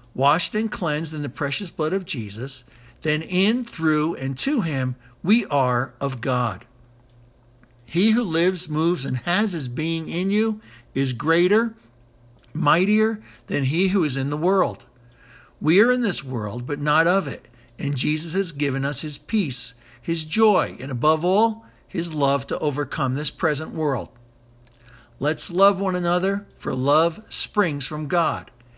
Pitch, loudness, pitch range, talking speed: 150 Hz, -22 LUFS, 125-180 Hz, 160 wpm